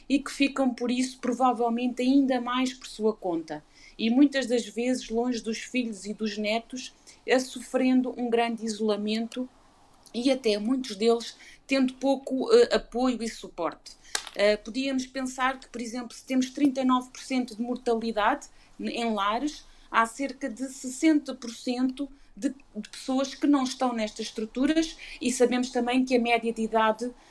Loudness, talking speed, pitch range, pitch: -27 LUFS, 150 wpm, 230-265 Hz, 250 Hz